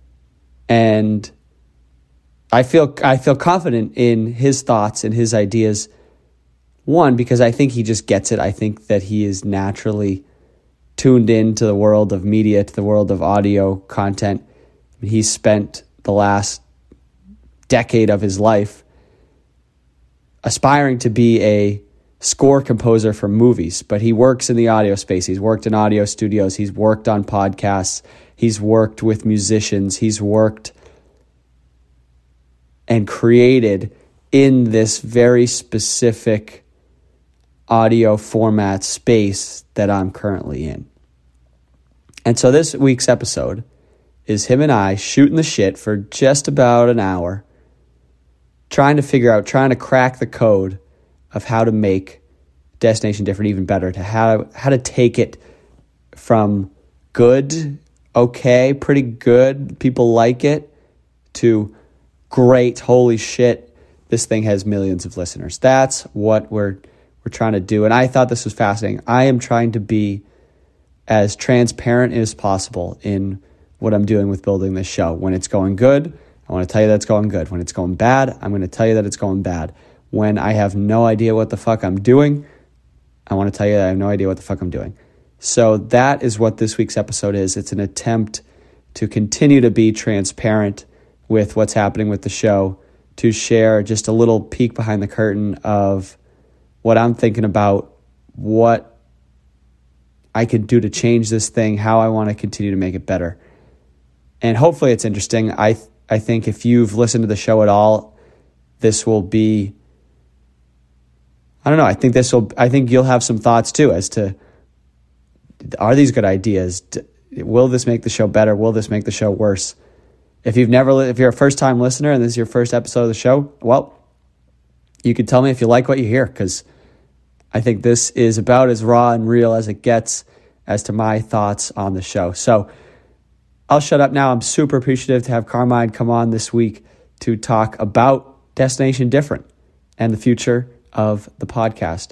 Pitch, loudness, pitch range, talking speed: 110 Hz, -15 LUFS, 95-120 Hz, 170 wpm